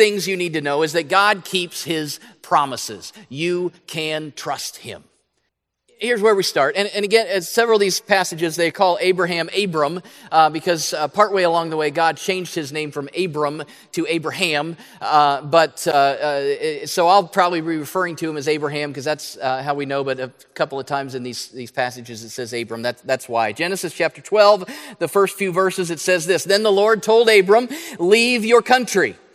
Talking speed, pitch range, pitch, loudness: 200 wpm, 150-200 Hz, 170 Hz, -19 LUFS